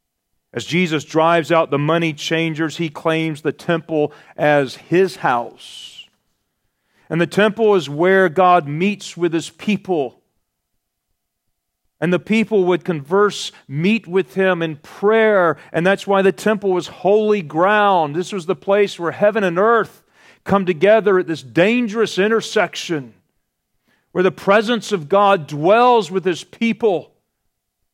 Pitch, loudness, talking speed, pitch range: 185 Hz, -17 LUFS, 140 wpm, 160-200 Hz